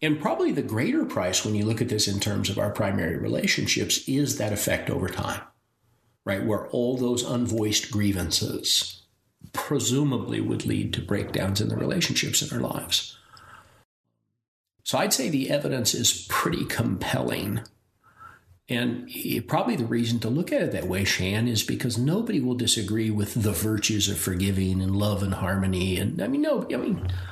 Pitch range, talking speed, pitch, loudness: 95-120 Hz, 170 wpm, 105 Hz, -25 LUFS